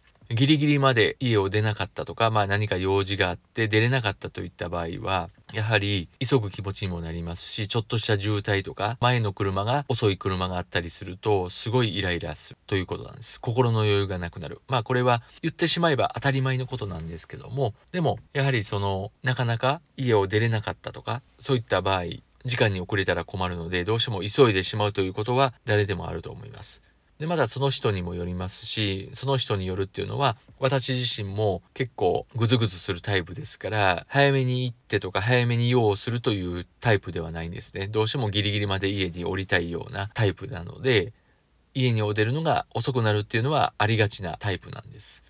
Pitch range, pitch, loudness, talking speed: 95-125 Hz, 105 Hz, -25 LUFS, 430 characters per minute